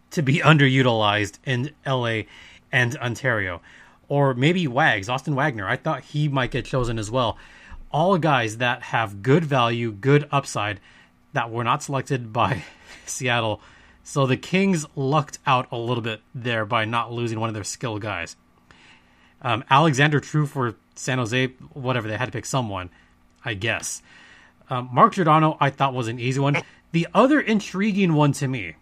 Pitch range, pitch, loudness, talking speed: 115-145 Hz, 130 Hz, -22 LUFS, 165 wpm